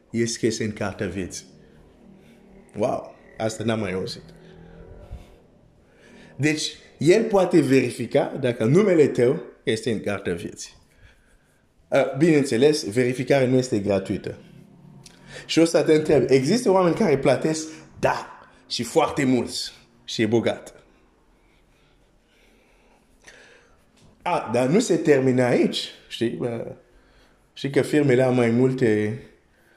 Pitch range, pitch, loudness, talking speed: 105-150 Hz, 125 Hz, -22 LUFS, 120 wpm